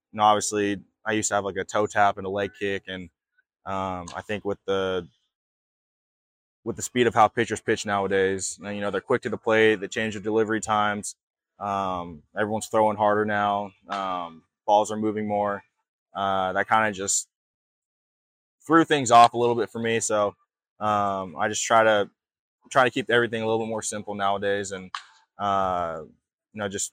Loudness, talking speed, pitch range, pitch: -24 LUFS, 185 wpm, 100-110 Hz, 105 Hz